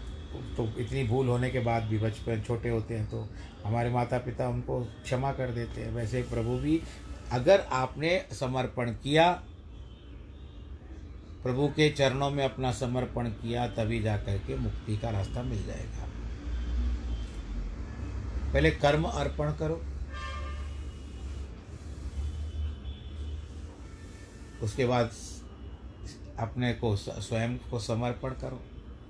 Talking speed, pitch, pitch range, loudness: 110 wpm, 110 Hz, 75-125 Hz, -31 LUFS